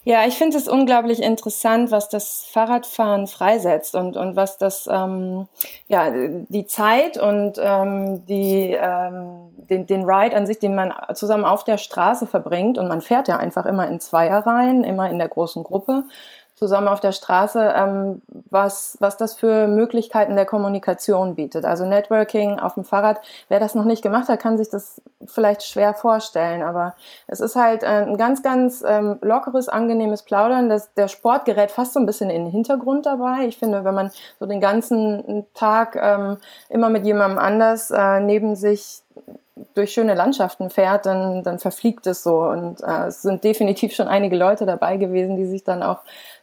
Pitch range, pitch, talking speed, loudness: 195-225 Hz, 205 Hz, 180 wpm, -19 LUFS